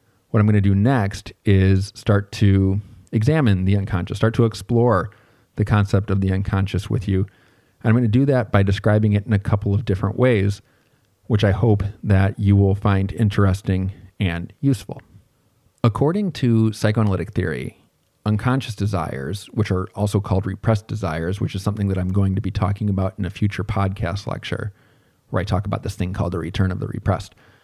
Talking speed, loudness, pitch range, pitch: 185 wpm, -21 LUFS, 95-115 Hz, 100 Hz